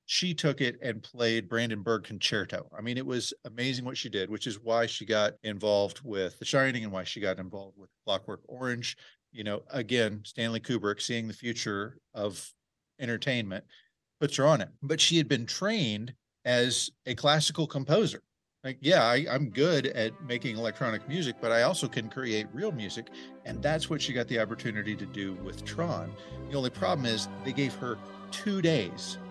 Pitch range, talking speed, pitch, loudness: 105-135 Hz, 185 wpm, 120 Hz, -30 LUFS